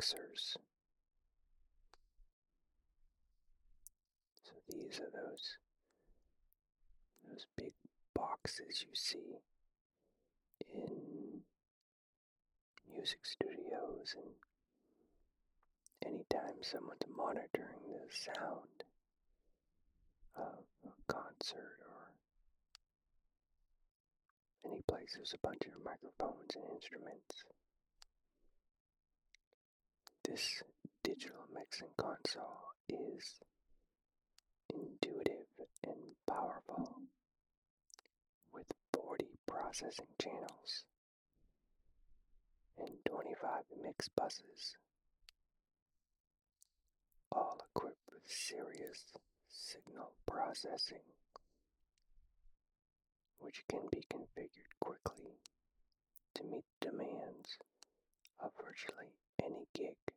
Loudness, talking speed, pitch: -47 LUFS, 65 wpm, 385 Hz